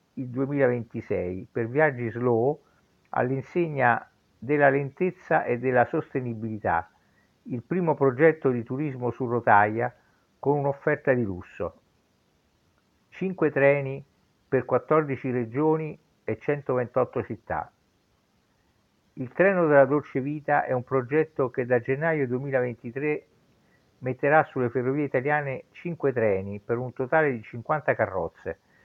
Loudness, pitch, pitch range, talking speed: -26 LUFS, 135 Hz, 120-150 Hz, 110 wpm